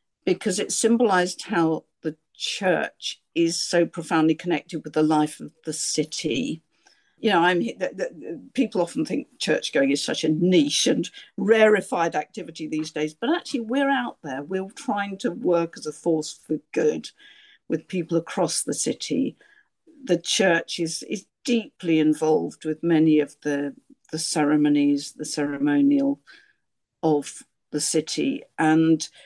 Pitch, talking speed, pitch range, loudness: 165 Hz, 145 wpm, 155-220 Hz, -24 LUFS